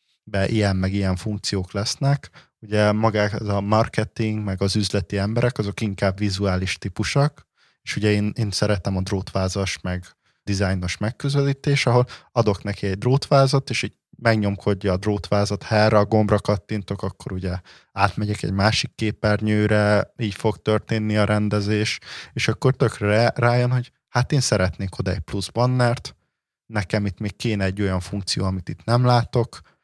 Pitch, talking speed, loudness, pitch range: 105 Hz, 155 wpm, -22 LUFS, 100-115 Hz